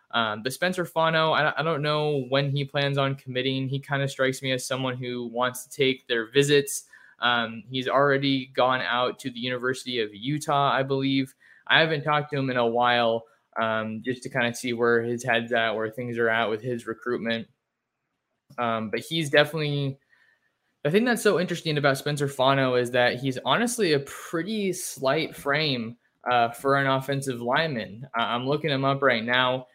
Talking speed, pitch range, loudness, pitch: 190 wpm, 120-140 Hz, -25 LUFS, 130 Hz